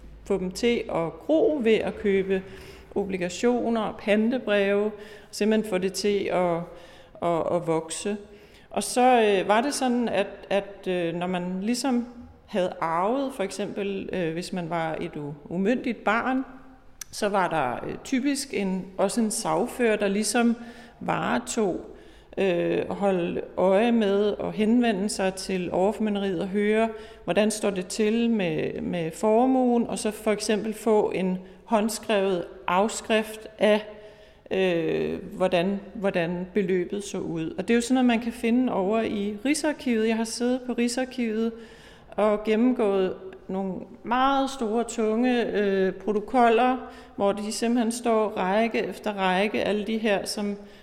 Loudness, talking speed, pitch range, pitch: -25 LUFS, 140 wpm, 190-230 Hz, 210 Hz